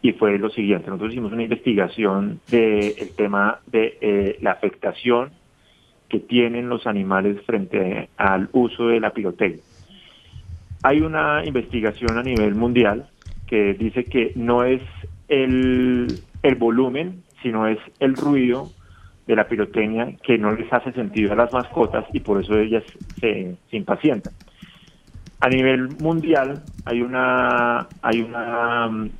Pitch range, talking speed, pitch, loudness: 105-125 Hz, 140 wpm, 115 Hz, -21 LUFS